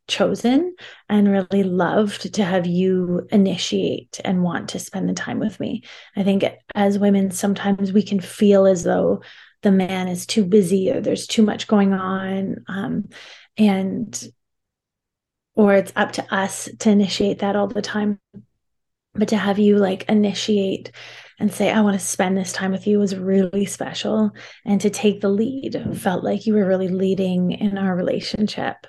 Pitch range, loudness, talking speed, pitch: 190-210 Hz, -20 LUFS, 170 wpm, 200 Hz